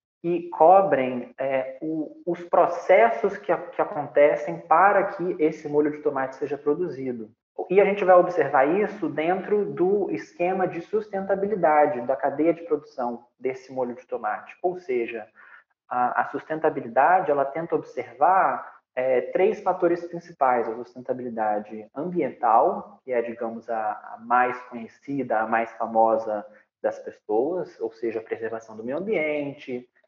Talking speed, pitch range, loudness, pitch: 140 wpm, 125-185 Hz, -24 LUFS, 155 Hz